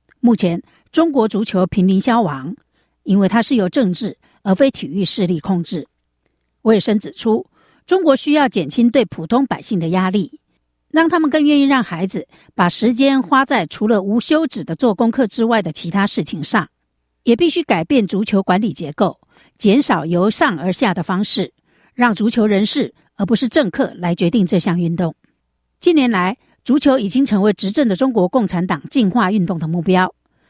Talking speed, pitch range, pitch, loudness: 270 characters per minute, 185-260 Hz, 215 Hz, -16 LUFS